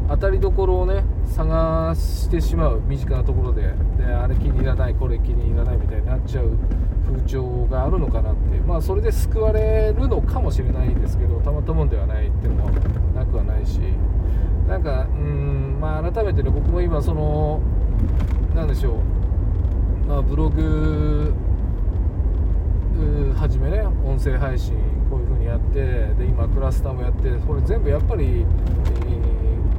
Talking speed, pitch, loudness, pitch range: 325 characters per minute, 80 Hz, -21 LUFS, 75-90 Hz